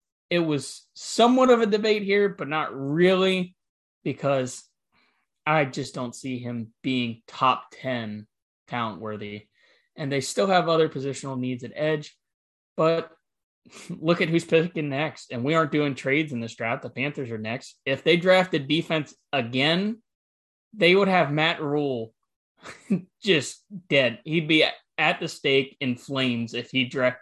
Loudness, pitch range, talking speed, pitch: -24 LUFS, 125-170 Hz, 155 wpm, 145 Hz